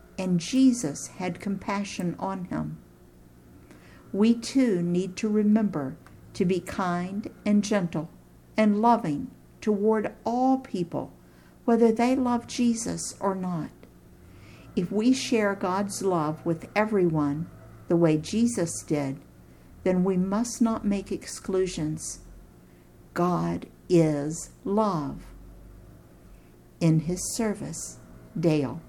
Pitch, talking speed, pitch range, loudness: 185 Hz, 105 wpm, 145-210 Hz, -26 LUFS